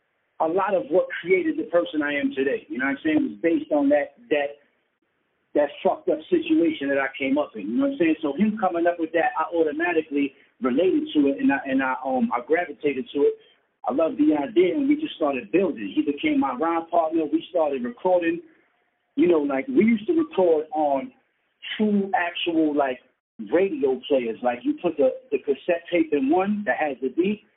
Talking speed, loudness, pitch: 210 wpm, -23 LUFS, 175 Hz